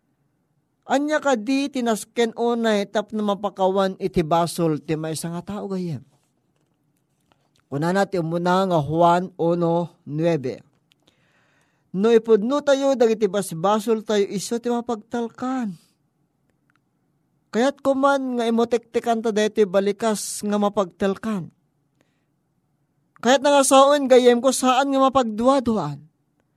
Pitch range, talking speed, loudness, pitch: 155-235 Hz, 100 wpm, -21 LUFS, 195 Hz